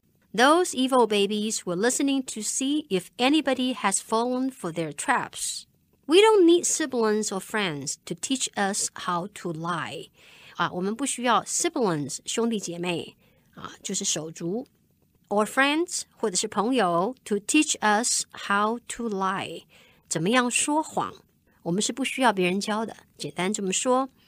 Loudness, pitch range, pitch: -25 LUFS, 185-255 Hz, 215 Hz